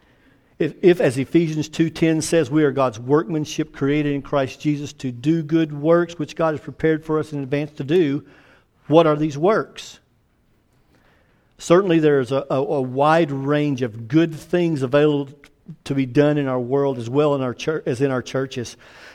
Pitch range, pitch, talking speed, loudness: 135-160 Hz, 145 Hz, 185 wpm, -20 LUFS